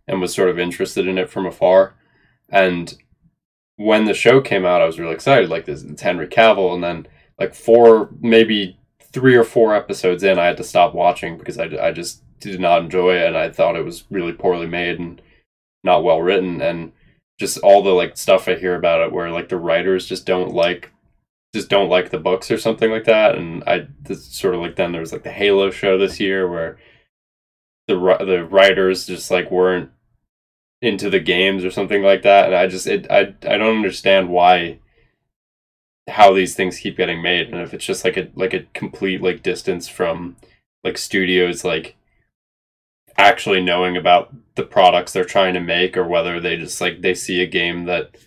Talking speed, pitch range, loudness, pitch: 200 wpm, 85-100 Hz, -16 LUFS, 90 Hz